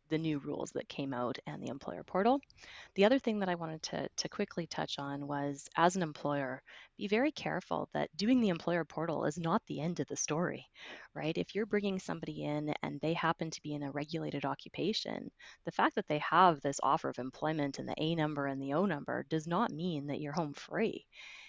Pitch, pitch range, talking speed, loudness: 160 Hz, 145-180 Hz, 220 wpm, -35 LUFS